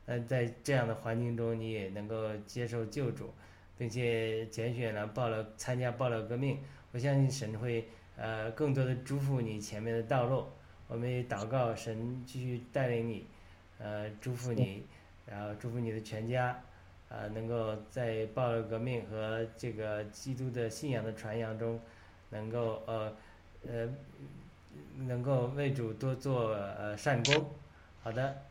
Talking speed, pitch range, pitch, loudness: 220 characters per minute, 110-125 Hz, 115 Hz, -36 LUFS